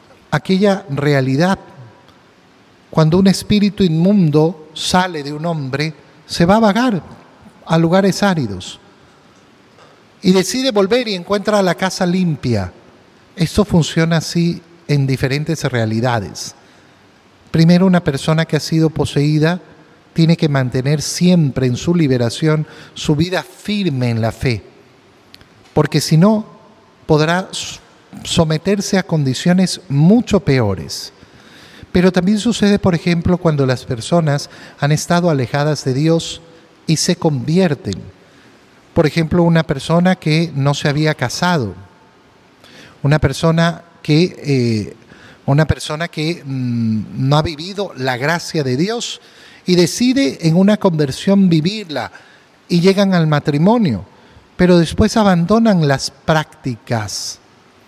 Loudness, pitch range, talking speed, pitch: -15 LUFS, 140-180 Hz, 120 wpm, 160 Hz